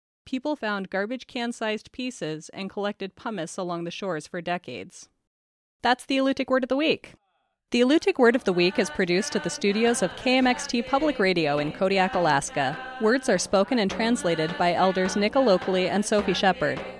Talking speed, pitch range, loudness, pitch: 175 wpm, 180-245 Hz, -25 LUFS, 200 Hz